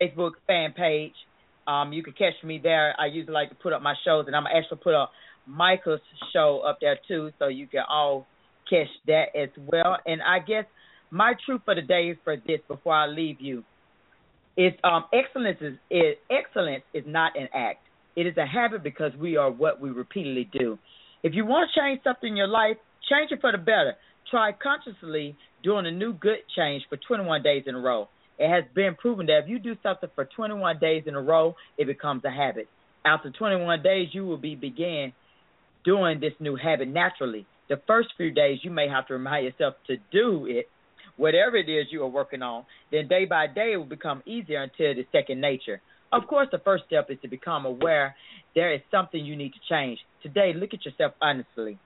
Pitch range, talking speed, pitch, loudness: 145-195 Hz, 210 wpm, 160 Hz, -26 LUFS